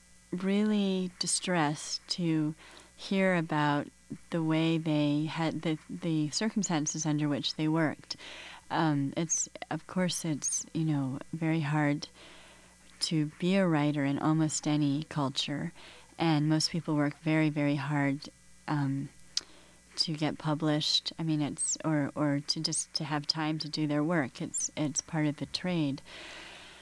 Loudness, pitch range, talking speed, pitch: -31 LUFS, 145-160 Hz, 145 wpm, 155 Hz